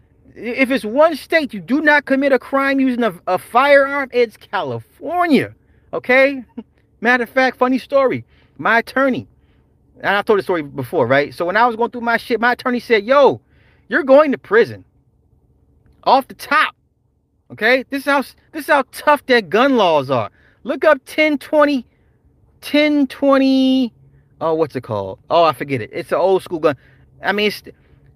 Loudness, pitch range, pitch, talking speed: -16 LUFS, 190-275 Hz, 250 Hz, 175 wpm